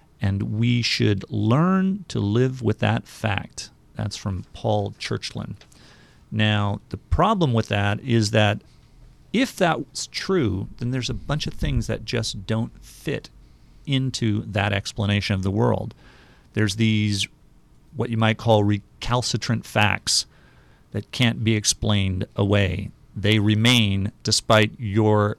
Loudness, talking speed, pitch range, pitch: -23 LUFS, 130 wpm, 100-120 Hz, 110 Hz